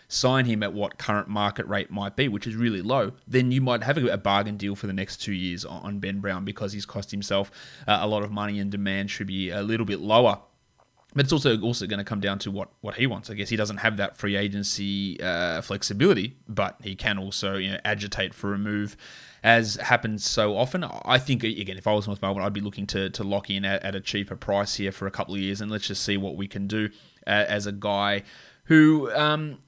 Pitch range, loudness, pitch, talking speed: 100-110 Hz, -26 LUFS, 100 Hz, 245 wpm